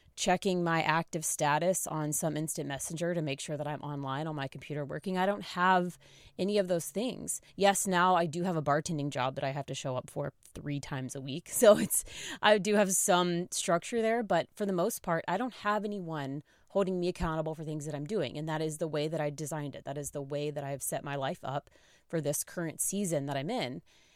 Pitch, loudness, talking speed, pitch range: 160 Hz, -32 LUFS, 235 wpm, 145-180 Hz